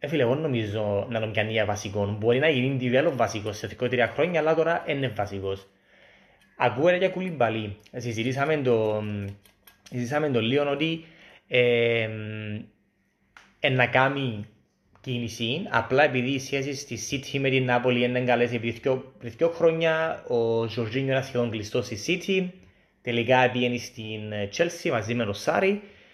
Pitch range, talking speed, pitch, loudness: 110-140 Hz, 160 wpm, 120 Hz, -25 LUFS